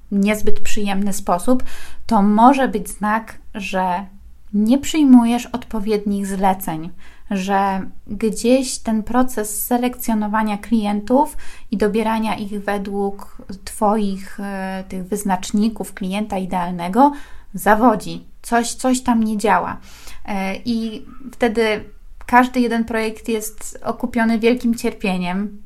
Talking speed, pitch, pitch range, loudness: 100 wpm, 215 Hz, 200-235 Hz, -19 LUFS